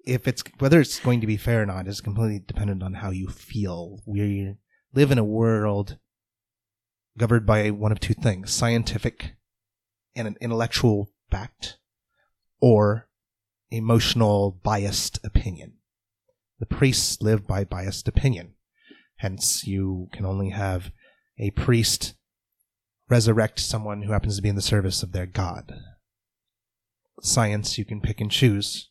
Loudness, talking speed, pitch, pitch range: -24 LUFS, 140 wpm, 105 Hz, 100-115 Hz